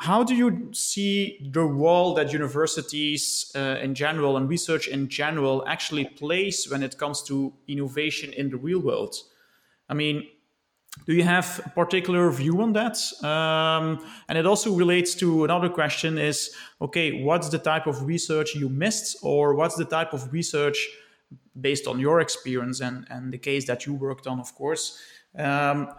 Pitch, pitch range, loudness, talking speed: 155 Hz, 140-175 Hz, -25 LUFS, 170 wpm